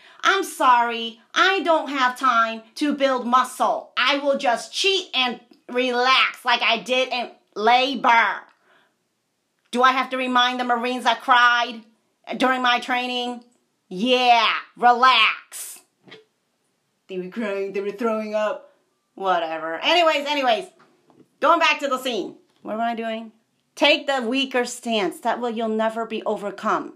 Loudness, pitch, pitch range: -20 LUFS, 245 Hz, 230-275 Hz